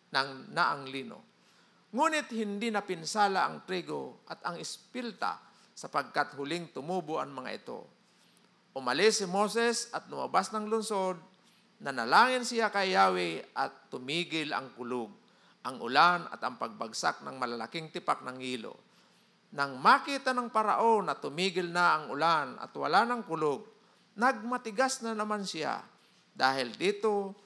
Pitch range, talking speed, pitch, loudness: 145-220 Hz, 135 wpm, 190 Hz, -31 LUFS